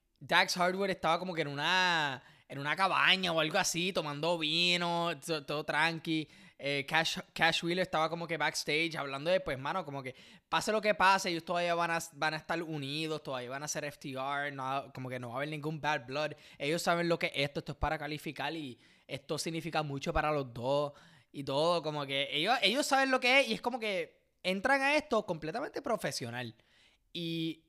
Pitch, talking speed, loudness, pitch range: 160 Hz, 205 wpm, -32 LUFS, 145-175 Hz